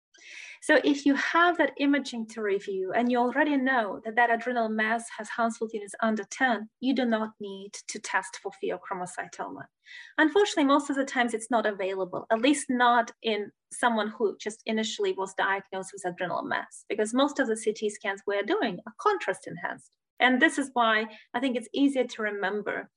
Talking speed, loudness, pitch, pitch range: 185 wpm, -27 LUFS, 230 Hz, 210-265 Hz